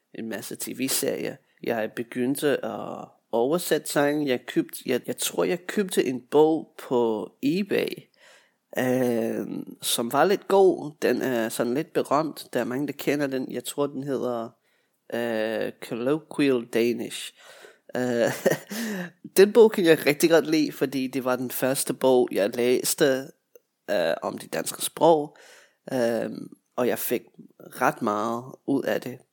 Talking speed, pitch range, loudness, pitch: 145 wpm, 120-155 Hz, -25 LUFS, 135 Hz